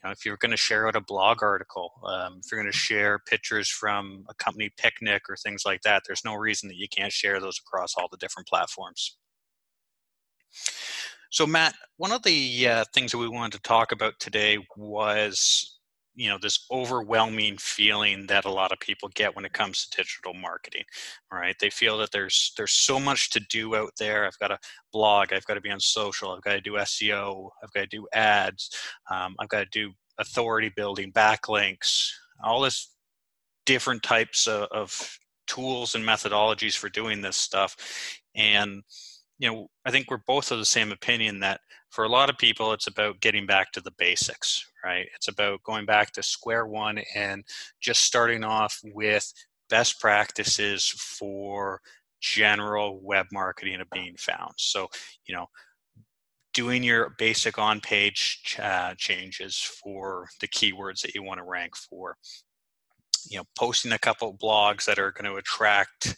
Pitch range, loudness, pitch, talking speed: 100-110 Hz, -25 LUFS, 105 Hz, 180 wpm